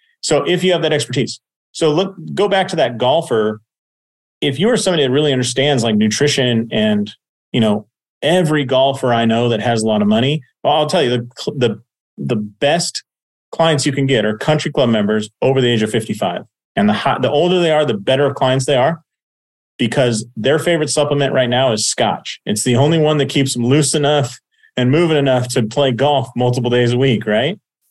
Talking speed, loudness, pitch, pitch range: 205 wpm, -15 LUFS, 130 Hz, 115-150 Hz